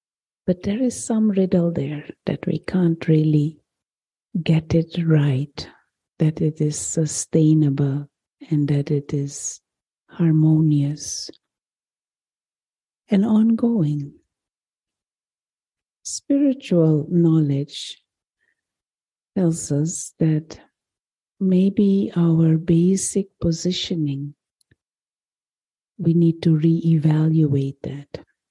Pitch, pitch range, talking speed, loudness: 160 Hz, 150-180 Hz, 80 wpm, -20 LUFS